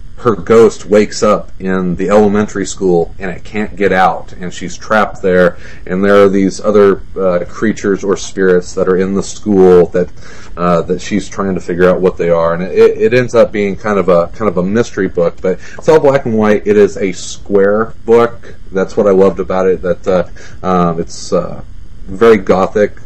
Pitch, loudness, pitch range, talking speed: 95 Hz, -12 LUFS, 90-105 Hz, 210 wpm